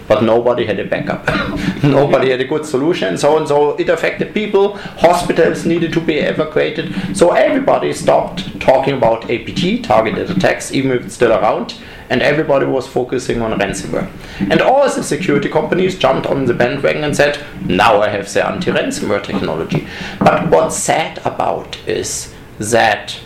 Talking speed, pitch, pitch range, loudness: 165 wpm, 145 Hz, 135-170 Hz, -15 LUFS